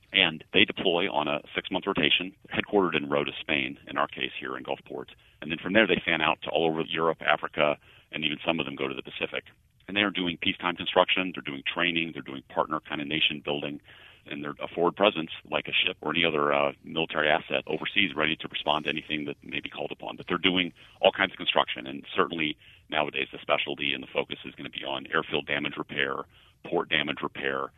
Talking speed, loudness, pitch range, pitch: 225 wpm, -27 LUFS, 70-90 Hz, 80 Hz